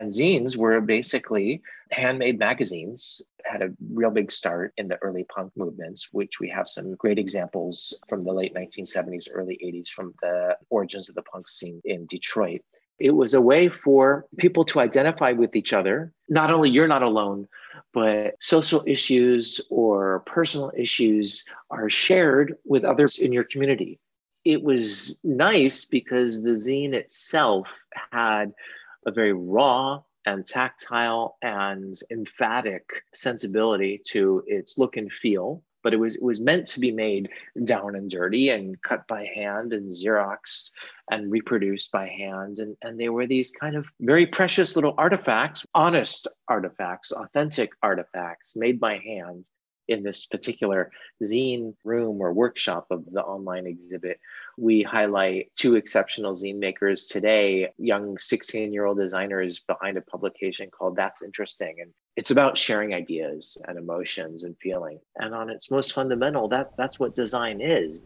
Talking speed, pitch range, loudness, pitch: 155 wpm, 100-135 Hz, -24 LUFS, 110 Hz